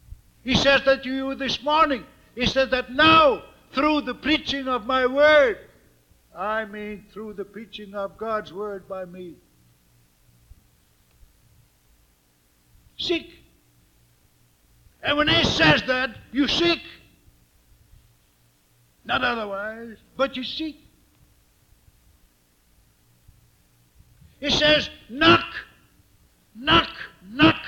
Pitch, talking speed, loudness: 215 Hz, 100 wpm, -21 LUFS